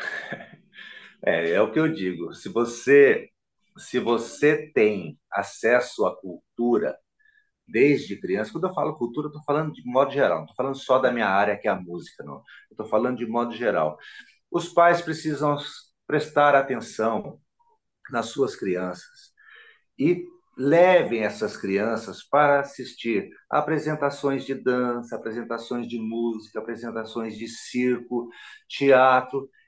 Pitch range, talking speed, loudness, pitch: 120-155 Hz, 135 wpm, -24 LUFS, 135 Hz